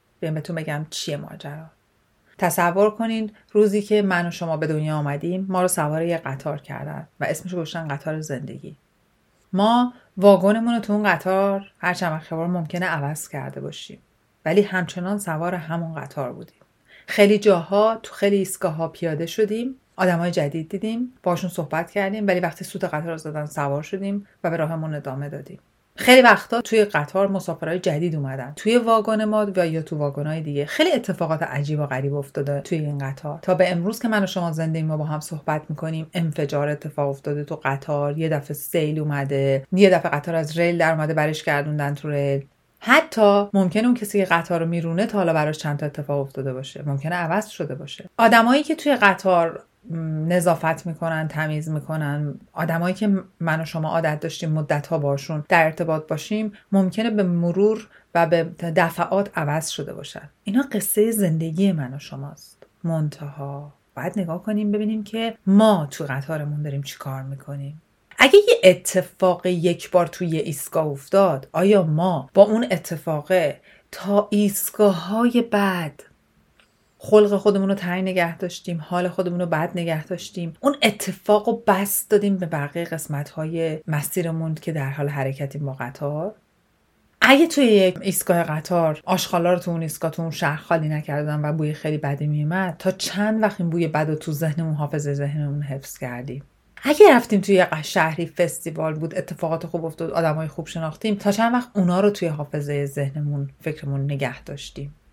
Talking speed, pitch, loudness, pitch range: 170 wpm, 165 Hz, -21 LUFS, 150-195 Hz